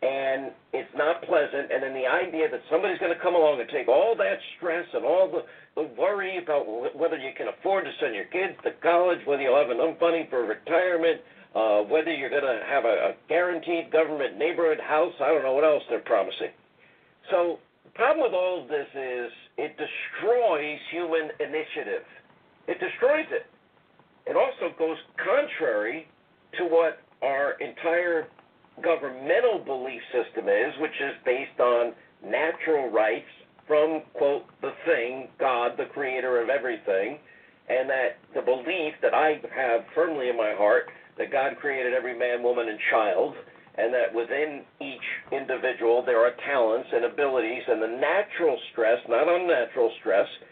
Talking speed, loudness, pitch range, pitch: 165 wpm, -26 LUFS, 135-200 Hz, 165 Hz